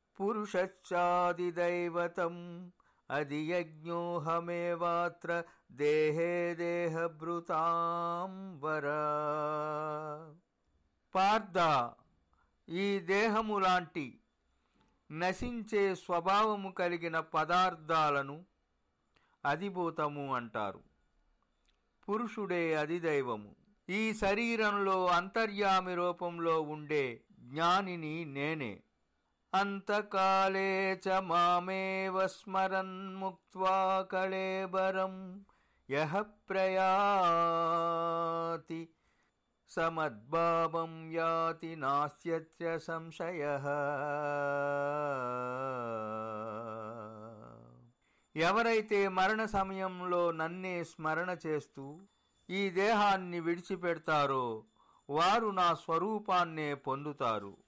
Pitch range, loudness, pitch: 155-190 Hz, -34 LUFS, 170 Hz